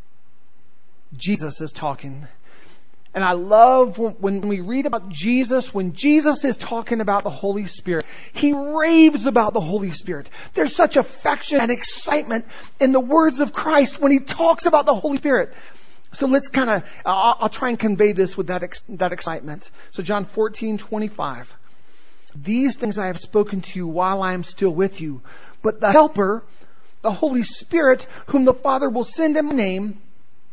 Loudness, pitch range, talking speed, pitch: -19 LUFS, 190-270 Hz, 175 wpm, 220 Hz